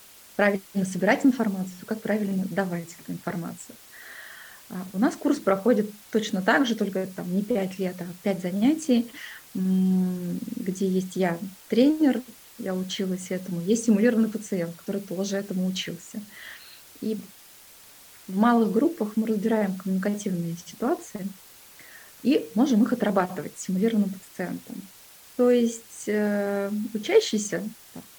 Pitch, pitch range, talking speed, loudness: 205 Hz, 190-225 Hz, 115 wpm, -26 LUFS